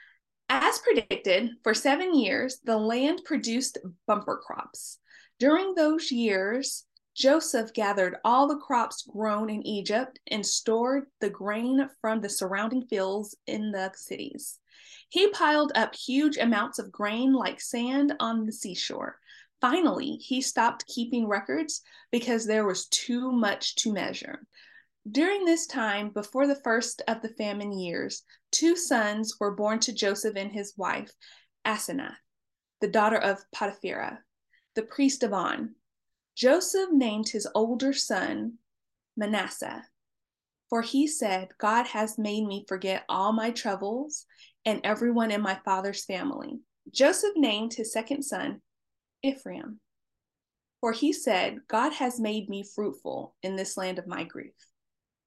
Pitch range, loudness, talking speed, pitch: 210-275 Hz, -28 LUFS, 140 wpm, 230 Hz